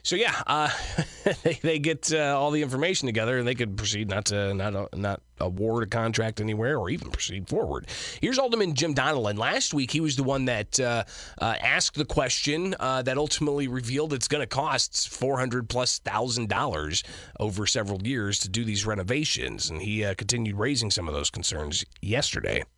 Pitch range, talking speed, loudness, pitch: 105-145 Hz, 195 wpm, -27 LUFS, 120 Hz